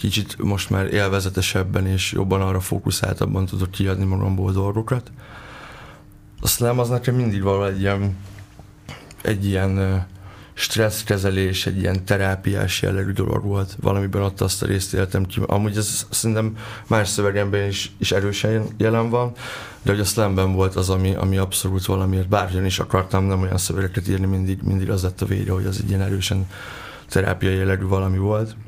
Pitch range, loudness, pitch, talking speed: 95-105 Hz, -21 LUFS, 100 Hz, 160 wpm